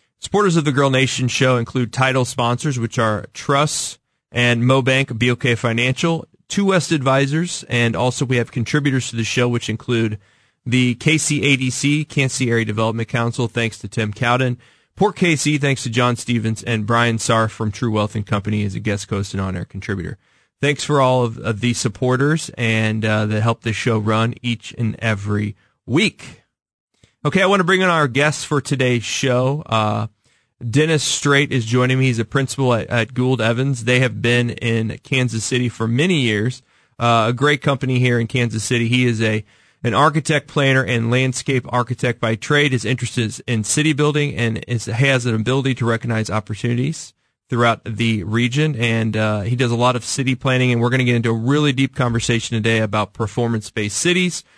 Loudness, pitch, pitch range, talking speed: -18 LUFS, 120 Hz, 115-135 Hz, 190 wpm